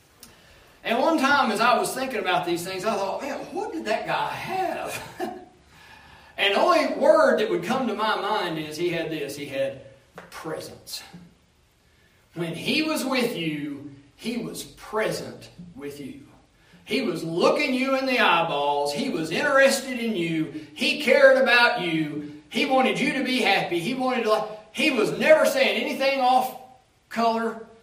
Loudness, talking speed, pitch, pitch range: -23 LUFS, 165 wpm, 230 Hz, 170-270 Hz